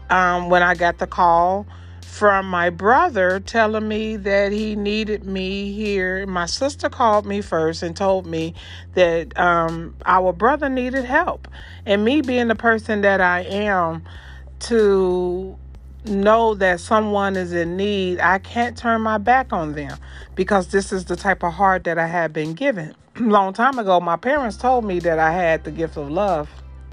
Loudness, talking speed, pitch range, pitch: -19 LUFS, 175 wpm, 170-215 Hz, 185 Hz